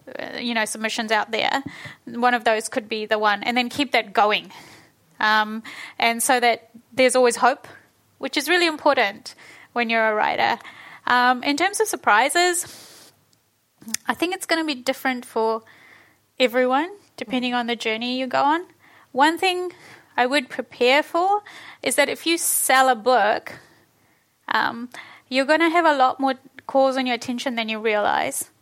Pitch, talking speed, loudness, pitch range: 255 Hz, 170 wpm, -21 LUFS, 230-295 Hz